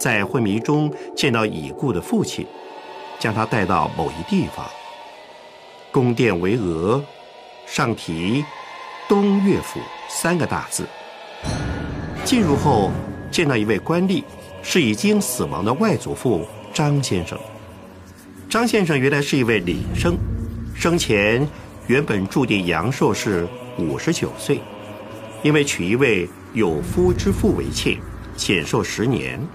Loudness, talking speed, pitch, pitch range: -20 LUFS, 185 characters per minute, 120 Hz, 100-155 Hz